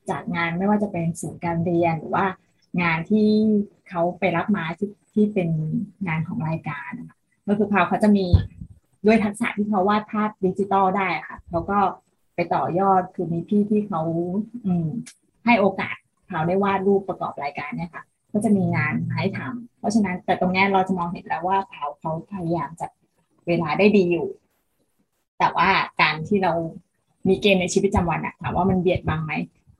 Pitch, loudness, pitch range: 185 Hz, -22 LUFS, 170-205 Hz